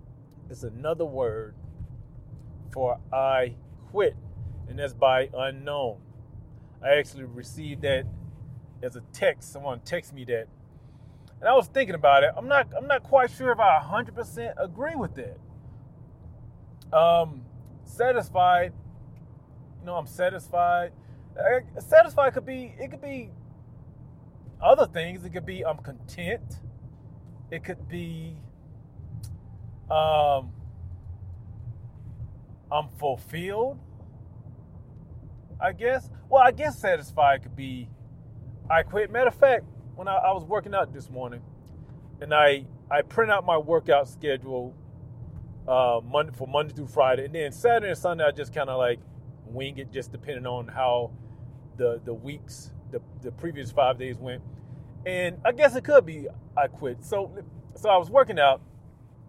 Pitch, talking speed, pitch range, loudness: 130 Hz, 140 wpm, 120-160 Hz, -25 LUFS